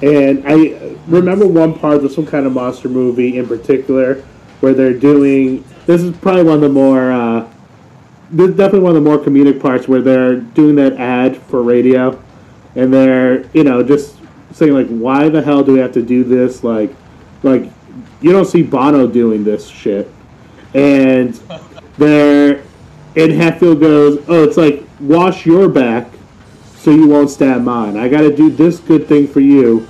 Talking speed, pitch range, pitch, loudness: 180 wpm, 125-155 Hz, 140 Hz, -11 LUFS